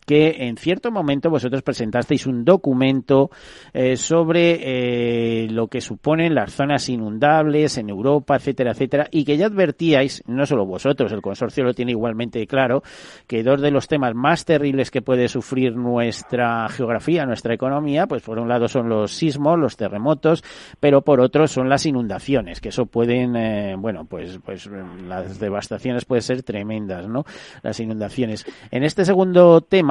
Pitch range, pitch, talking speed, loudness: 115-145 Hz, 130 Hz, 165 wpm, -19 LUFS